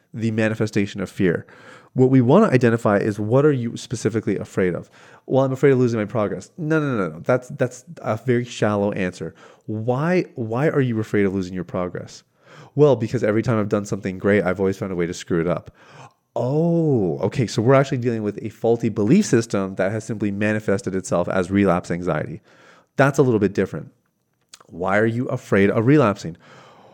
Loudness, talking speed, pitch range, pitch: -21 LUFS, 200 wpm, 100-130 Hz, 115 Hz